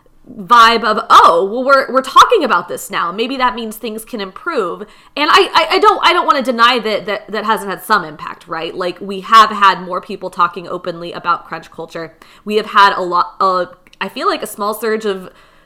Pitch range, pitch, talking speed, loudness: 185-235 Hz, 210 Hz, 220 wpm, -13 LUFS